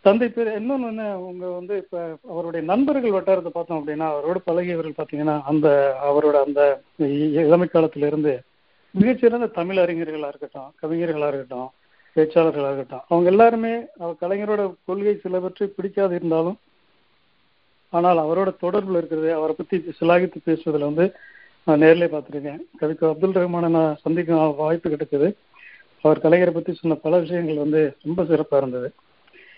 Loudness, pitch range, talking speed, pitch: -21 LUFS, 155-185 Hz, 130 wpm, 165 Hz